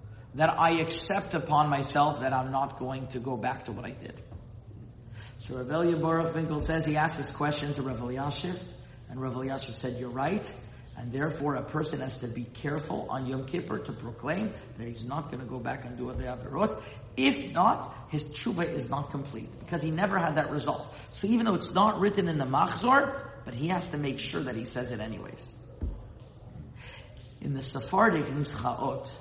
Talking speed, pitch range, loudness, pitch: 195 wpm, 125-160 Hz, -30 LUFS, 135 Hz